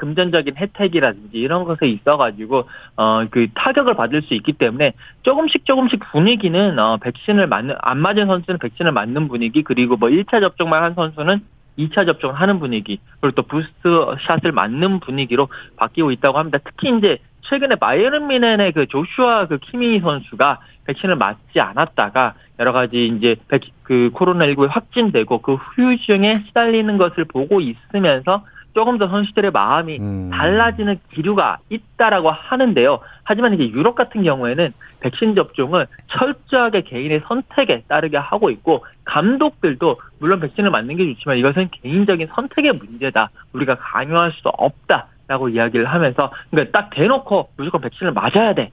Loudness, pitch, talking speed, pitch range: -17 LUFS, 170 Hz, 365 characters per minute, 135-210 Hz